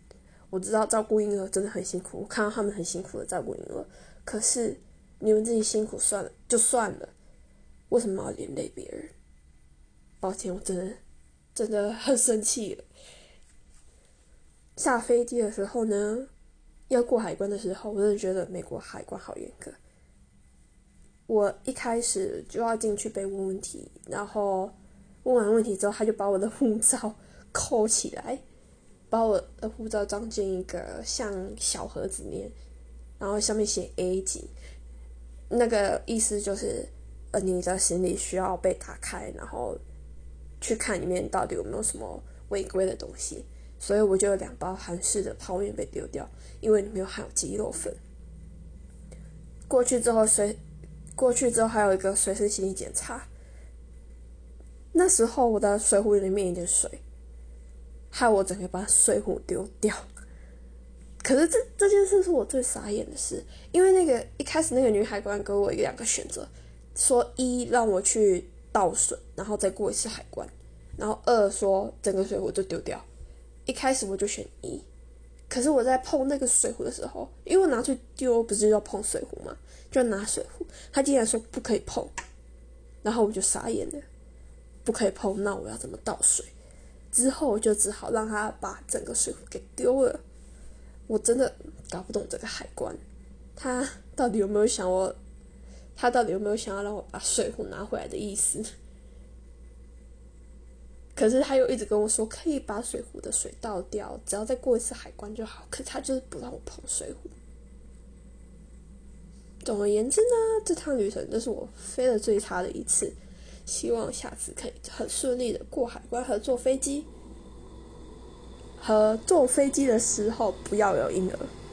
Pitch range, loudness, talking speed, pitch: 175-240 Hz, -27 LUFS, 245 characters per minute, 205 Hz